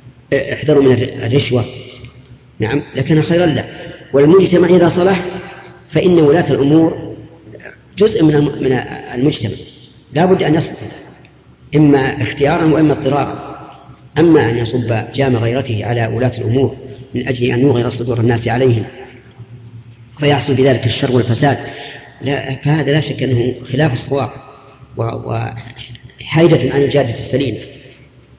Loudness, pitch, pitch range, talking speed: -14 LUFS, 135 Hz, 120-145 Hz, 115 wpm